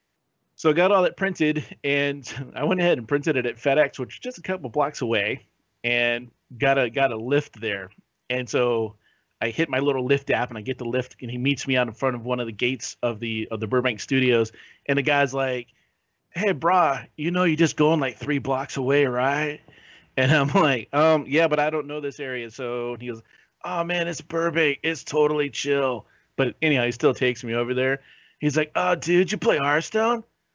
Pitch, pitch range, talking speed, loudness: 140 Hz, 125-155 Hz, 220 wpm, -24 LUFS